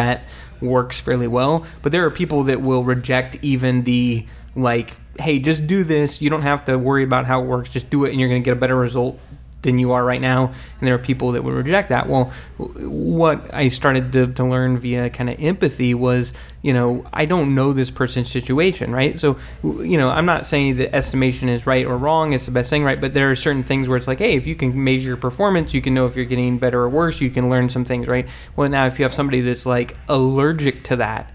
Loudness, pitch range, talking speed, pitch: -19 LUFS, 125-140 Hz, 250 wpm, 130 Hz